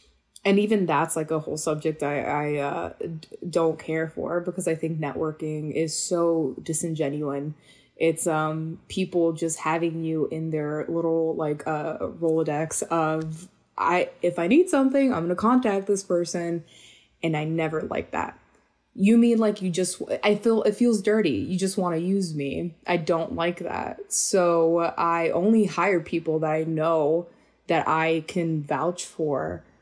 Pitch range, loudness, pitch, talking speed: 155-180 Hz, -25 LUFS, 165 Hz, 165 wpm